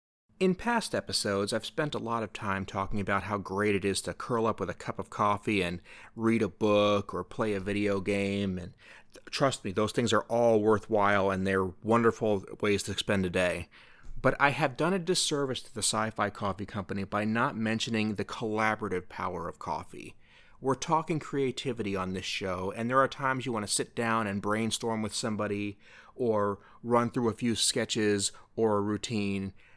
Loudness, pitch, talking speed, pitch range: -30 LUFS, 105 Hz, 190 wpm, 100-115 Hz